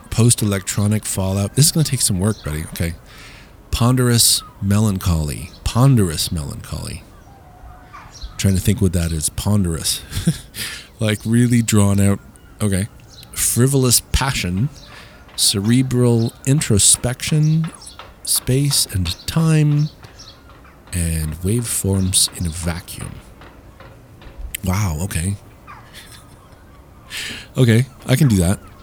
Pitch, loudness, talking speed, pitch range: 105 Hz, -17 LUFS, 100 wpm, 95-125 Hz